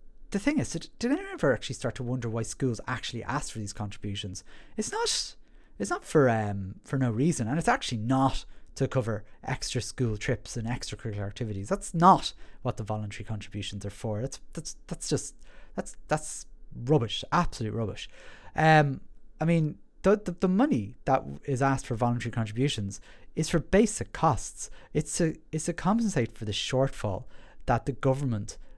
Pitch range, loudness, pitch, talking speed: 110-160 Hz, -29 LUFS, 130 Hz, 175 wpm